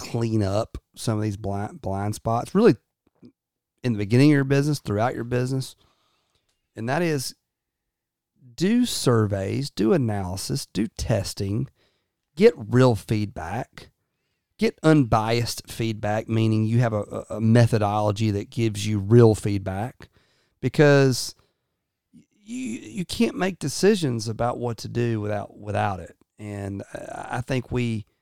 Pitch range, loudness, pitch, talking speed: 105-130 Hz, -23 LUFS, 115 Hz, 130 wpm